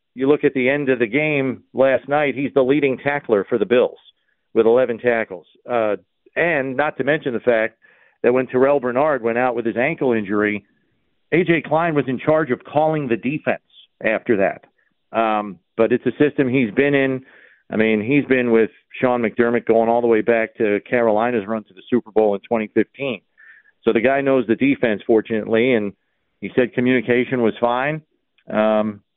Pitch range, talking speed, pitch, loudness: 115-140 Hz, 185 wpm, 125 Hz, -19 LUFS